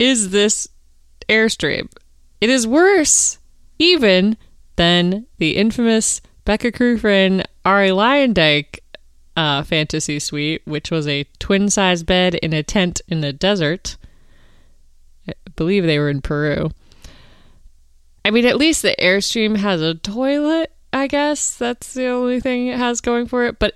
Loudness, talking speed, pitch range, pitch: -17 LUFS, 140 wpm, 155-240 Hz, 195 Hz